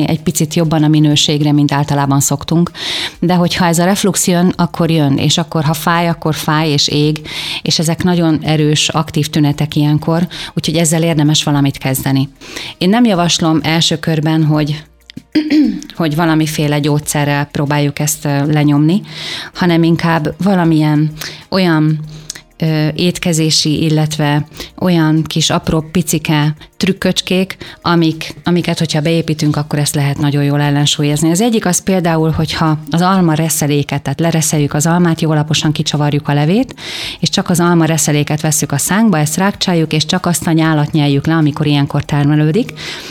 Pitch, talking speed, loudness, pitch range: 160 Hz, 150 wpm, -13 LUFS, 150-170 Hz